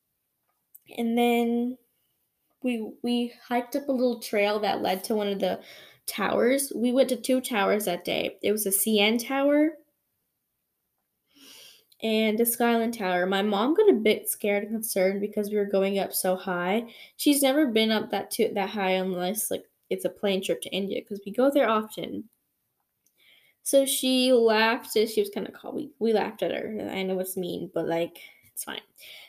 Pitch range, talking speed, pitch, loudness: 200-245 Hz, 180 wpm, 220 Hz, -26 LUFS